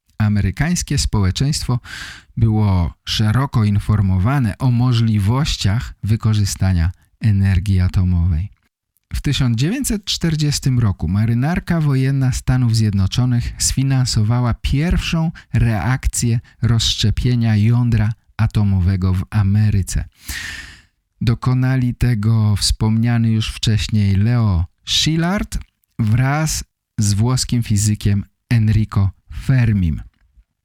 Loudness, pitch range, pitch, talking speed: -17 LUFS, 100-125 Hz, 110 Hz, 75 wpm